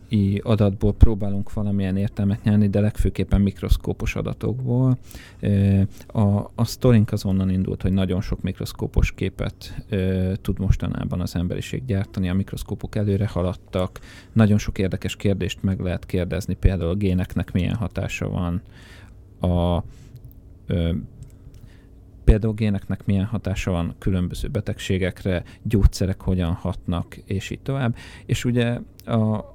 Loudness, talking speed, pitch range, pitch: -23 LUFS, 120 wpm, 95-110 Hz, 100 Hz